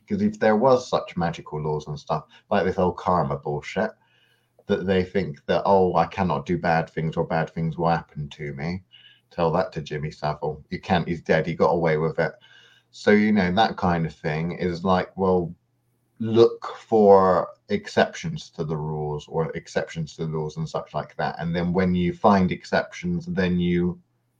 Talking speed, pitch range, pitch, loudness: 190 wpm, 80-105 Hz, 90 Hz, -24 LUFS